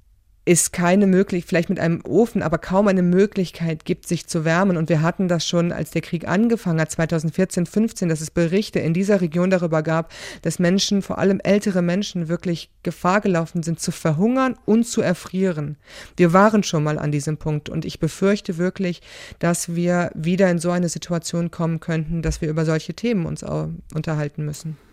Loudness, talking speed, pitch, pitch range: -21 LUFS, 190 wpm, 175 Hz, 165-190 Hz